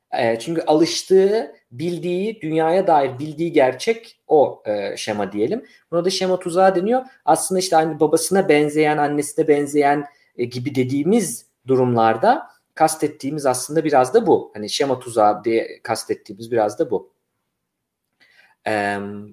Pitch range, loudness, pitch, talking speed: 125-180 Hz, -19 LUFS, 150 Hz, 120 wpm